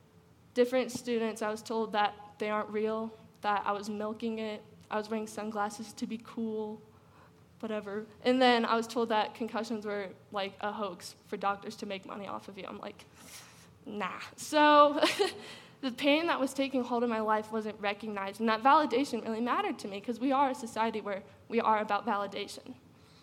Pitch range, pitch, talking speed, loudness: 210-240 Hz, 220 Hz, 190 wpm, -32 LUFS